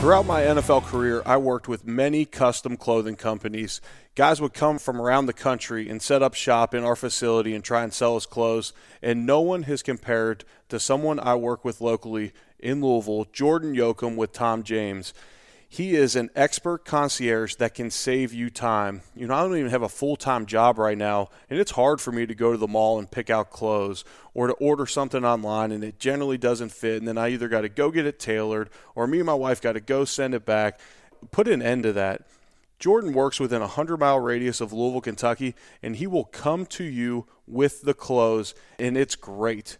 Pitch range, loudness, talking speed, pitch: 110-135 Hz, -24 LUFS, 215 wpm, 120 Hz